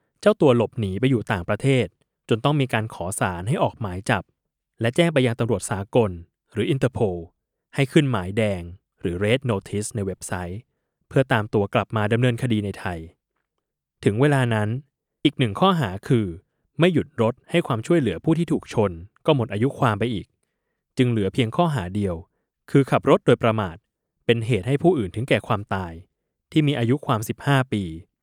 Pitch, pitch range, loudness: 115 Hz, 100-135 Hz, -23 LUFS